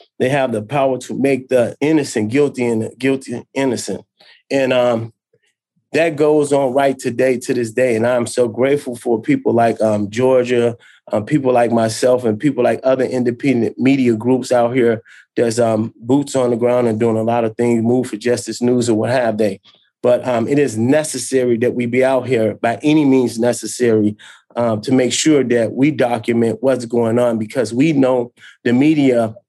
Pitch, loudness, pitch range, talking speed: 120 Hz, -16 LUFS, 115-130 Hz, 190 wpm